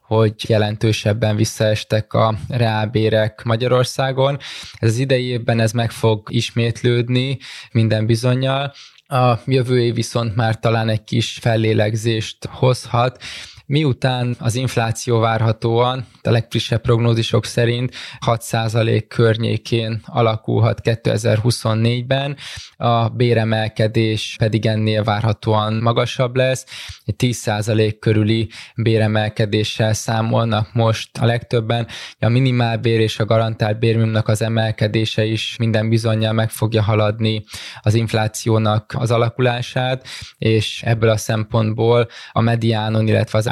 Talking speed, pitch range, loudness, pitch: 110 wpm, 110-120 Hz, -18 LUFS, 115 Hz